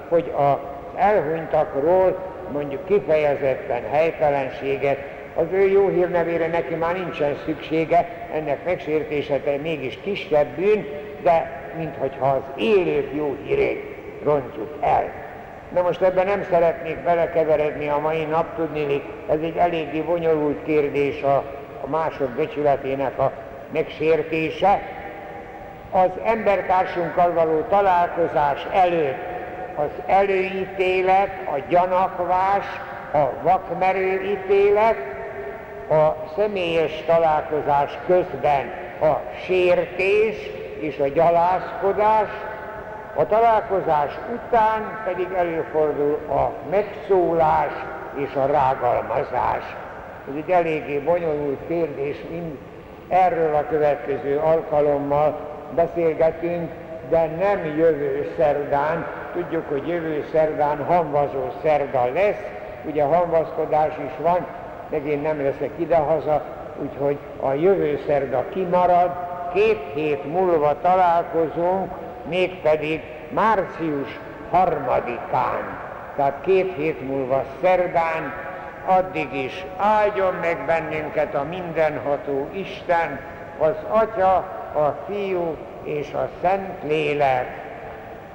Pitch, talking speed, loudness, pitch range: 165 Hz, 95 wpm, -22 LUFS, 150-185 Hz